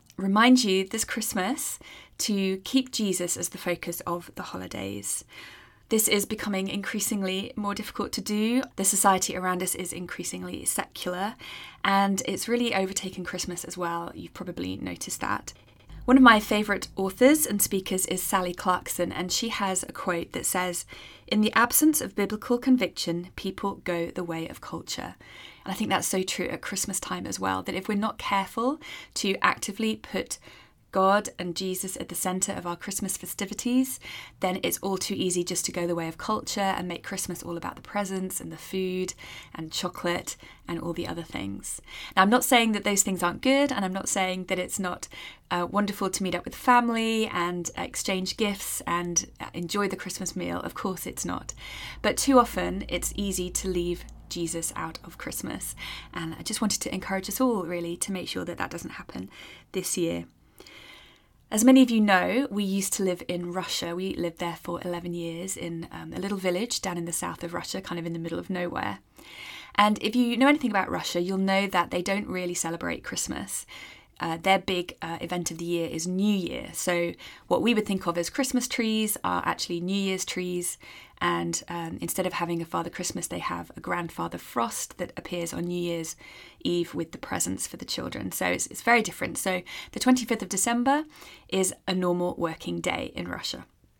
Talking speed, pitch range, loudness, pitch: 195 wpm, 175-210 Hz, -27 LUFS, 185 Hz